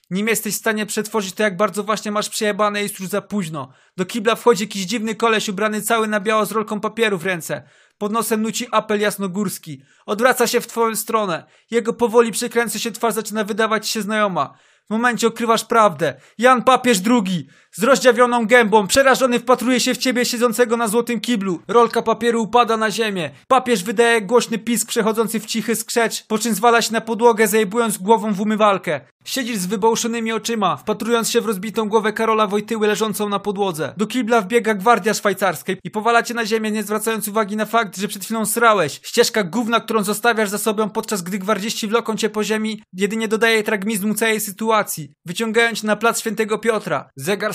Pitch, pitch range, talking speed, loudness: 220 Hz, 210-235 Hz, 185 wpm, -18 LUFS